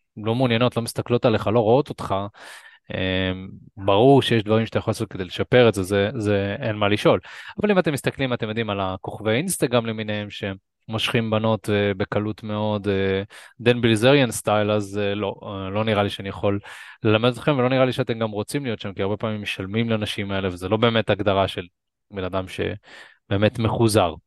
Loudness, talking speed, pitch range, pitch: -22 LUFS, 180 wpm, 100-115 Hz, 105 Hz